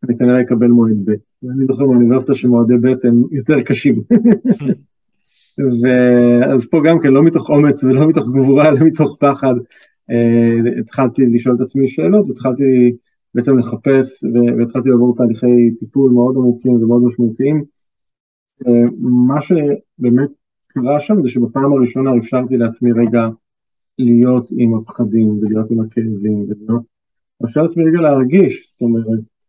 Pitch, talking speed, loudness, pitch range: 125 Hz, 135 wpm, -13 LUFS, 120-135 Hz